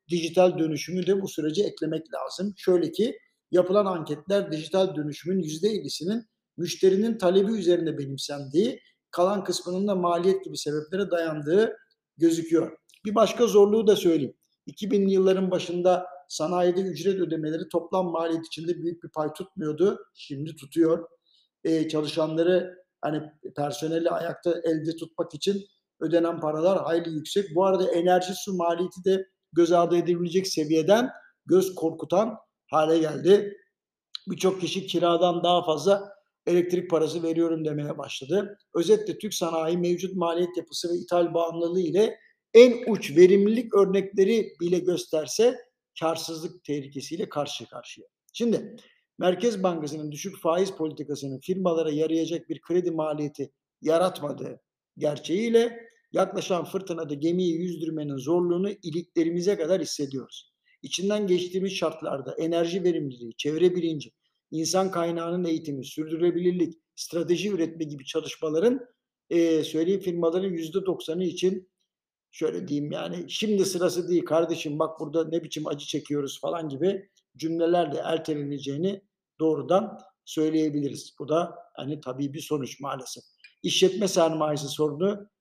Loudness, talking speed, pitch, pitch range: -26 LUFS, 120 wpm, 170 Hz, 160-190 Hz